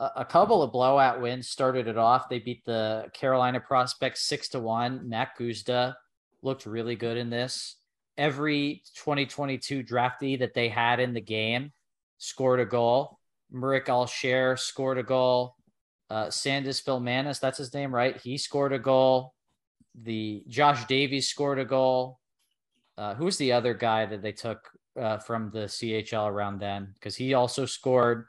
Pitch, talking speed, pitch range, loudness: 125 Hz, 160 wpm, 115-135 Hz, -27 LUFS